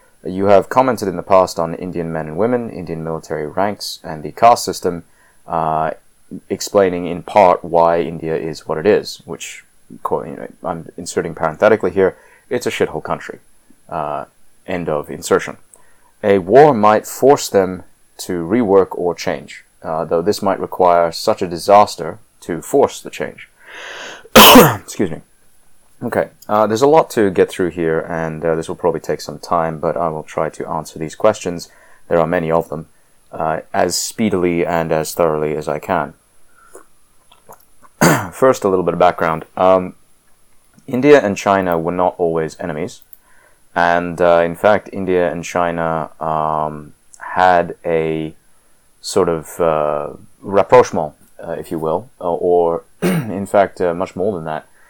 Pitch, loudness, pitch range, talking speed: 85 Hz, -16 LUFS, 80-95 Hz, 160 wpm